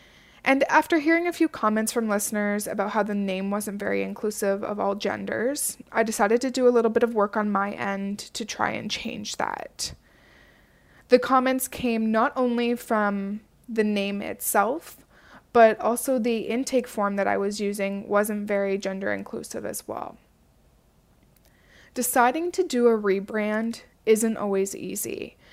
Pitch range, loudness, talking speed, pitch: 205-245 Hz, -25 LUFS, 160 wpm, 220 Hz